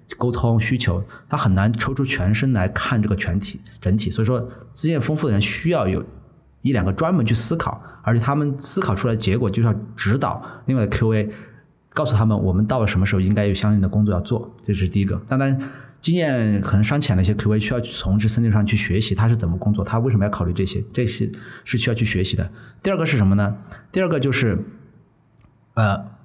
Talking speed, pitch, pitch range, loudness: 335 characters per minute, 110 Hz, 100-125 Hz, -21 LUFS